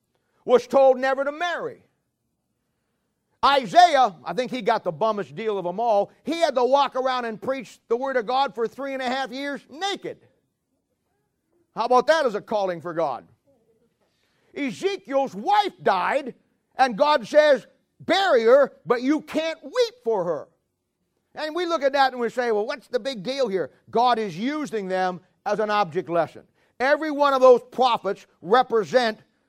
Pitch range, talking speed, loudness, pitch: 220-285 Hz, 170 wpm, -22 LUFS, 255 Hz